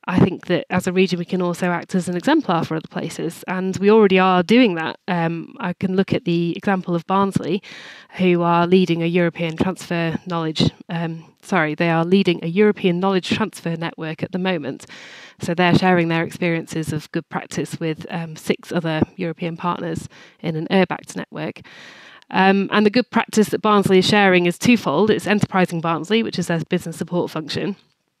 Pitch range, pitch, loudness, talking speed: 165-195 Hz, 180 Hz, -19 LUFS, 190 wpm